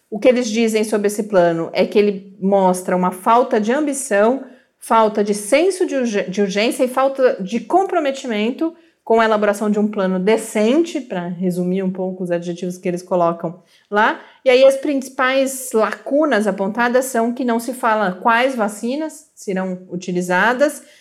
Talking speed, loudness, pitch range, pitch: 160 wpm, -18 LUFS, 190-265 Hz, 220 Hz